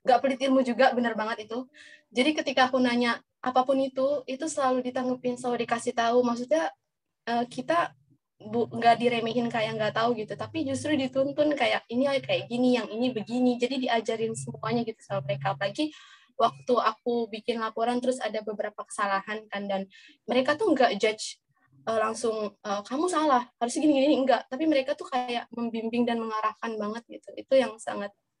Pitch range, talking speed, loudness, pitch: 220-265 Hz, 160 wpm, -27 LUFS, 240 Hz